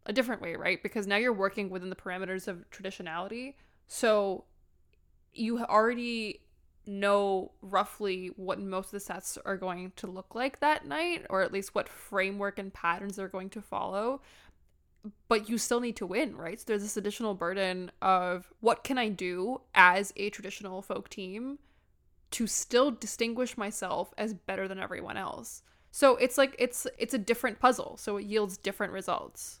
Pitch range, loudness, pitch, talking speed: 190-230 Hz, -31 LUFS, 200 Hz, 170 wpm